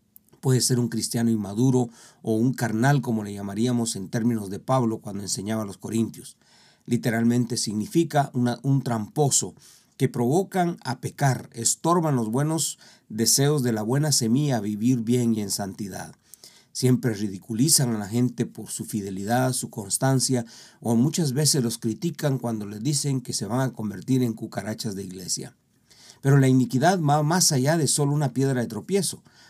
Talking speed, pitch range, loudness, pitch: 165 wpm, 110-135 Hz, -24 LUFS, 120 Hz